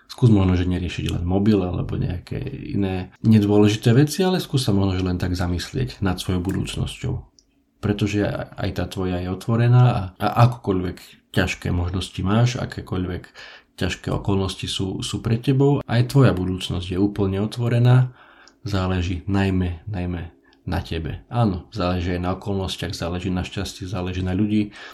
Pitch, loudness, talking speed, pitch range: 100 Hz, -22 LUFS, 150 wpm, 90-120 Hz